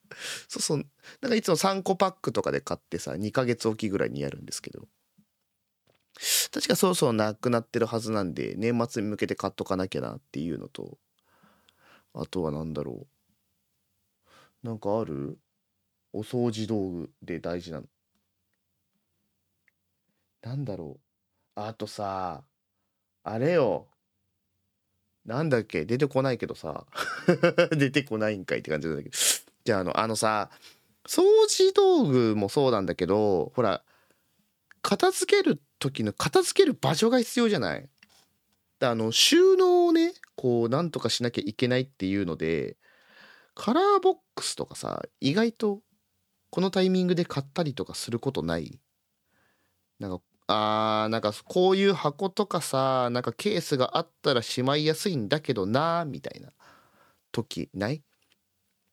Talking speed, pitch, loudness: 265 characters per minute, 115 Hz, -26 LUFS